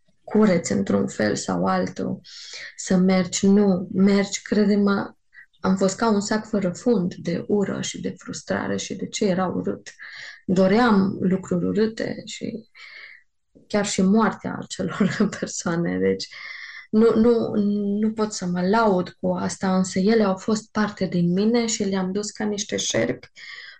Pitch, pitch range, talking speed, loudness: 200 Hz, 185-215 Hz, 150 wpm, -22 LUFS